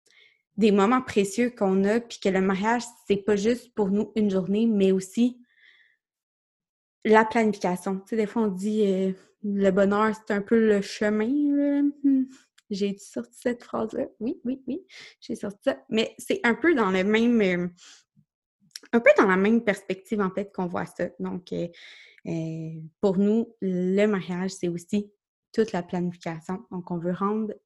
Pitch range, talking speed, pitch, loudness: 190-235 Hz, 175 wpm, 210 Hz, -25 LUFS